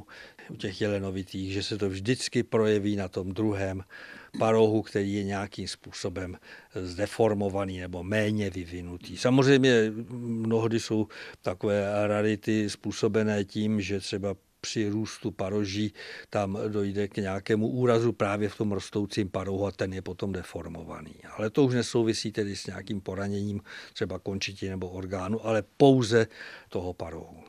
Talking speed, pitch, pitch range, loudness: 140 wpm, 105 Hz, 95-110 Hz, -29 LUFS